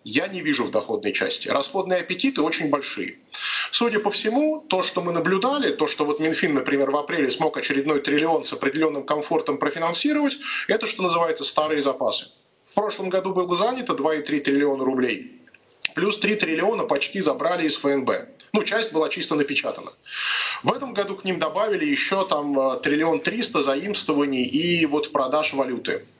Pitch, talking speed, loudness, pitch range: 165 Hz, 165 wpm, -23 LUFS, 150-210 Hz